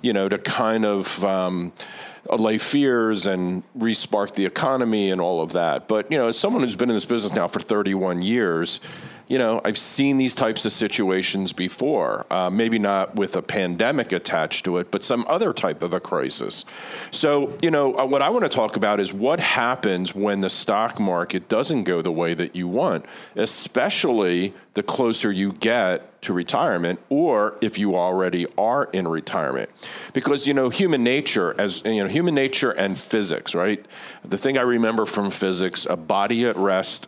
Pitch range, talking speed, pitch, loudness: 95-120 Hz, 190 wpm, 105 Hz, -21 LUFS